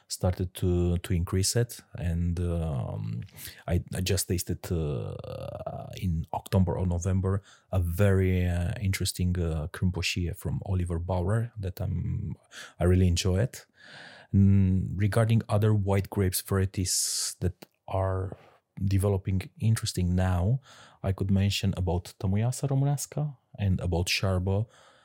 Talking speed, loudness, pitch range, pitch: 120 wpm, -28 LUFS, 90-110 Hz, 95 Hz